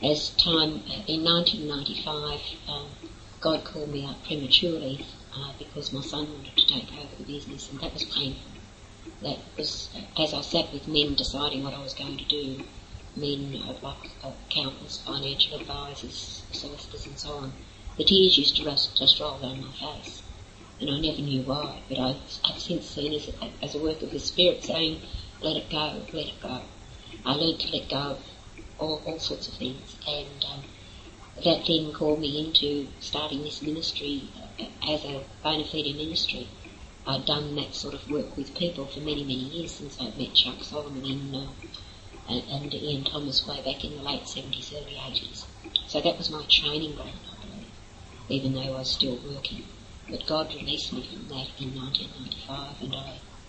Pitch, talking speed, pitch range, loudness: 140 Hz, 180 wpm, 125-150 Hz, -27 LUFS